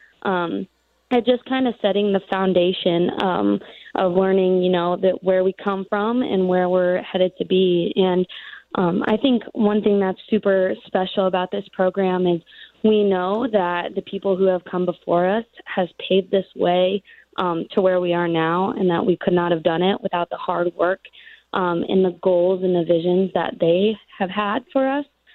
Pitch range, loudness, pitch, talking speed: 180-205 Hz, -20 LUFS, 190 Hz, 195 wpm